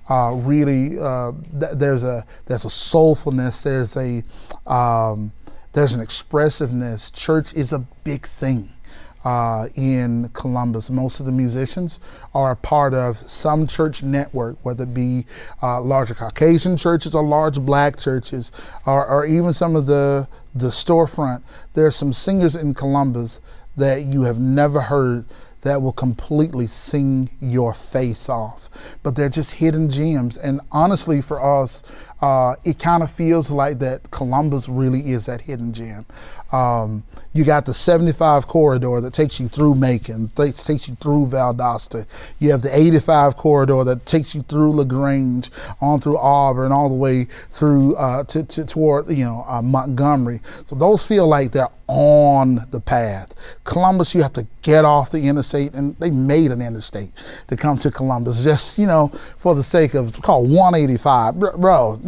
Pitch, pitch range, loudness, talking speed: 135 Hz, 125-150 Hz, -18 LUFS, 165 wpm